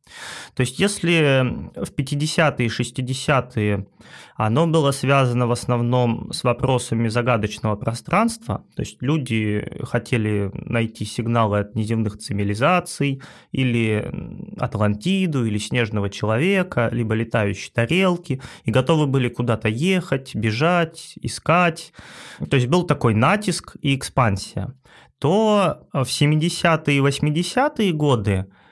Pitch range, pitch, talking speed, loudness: 115-160 Hz, 130 Hz, 110 wpm, -21 LUFS